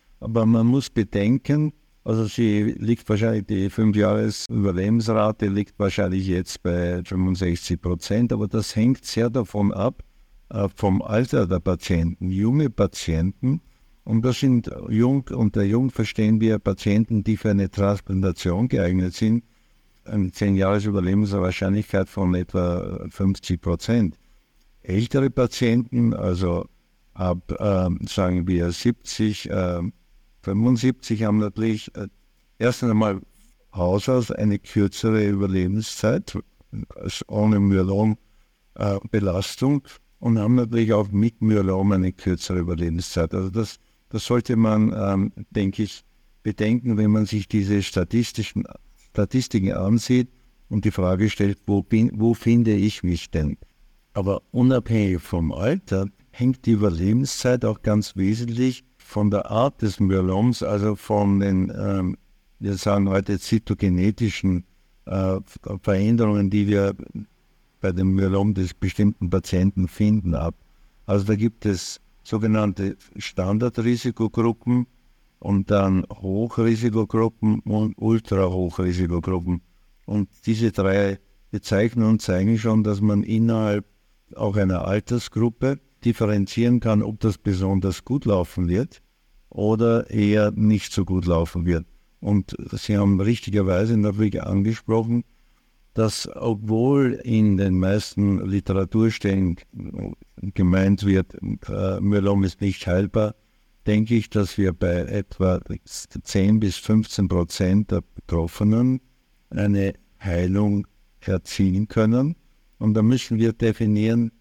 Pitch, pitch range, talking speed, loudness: 105 Hz, 95-115 Hz, 120 wpm, -22 LUFS